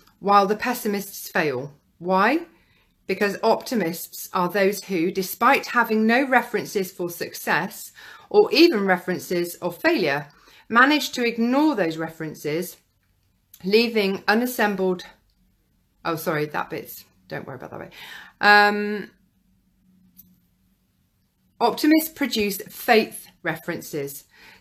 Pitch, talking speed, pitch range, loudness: 195 Hz, 100 wpm, 170-225 Hz, -22 LUFS